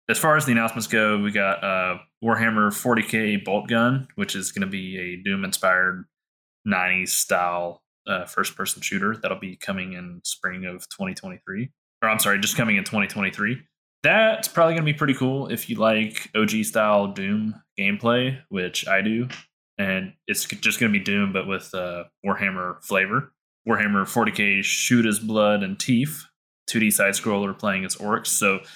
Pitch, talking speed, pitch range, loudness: 105 Hz, 175 wpm, 95-125 Hz, -22 LUFS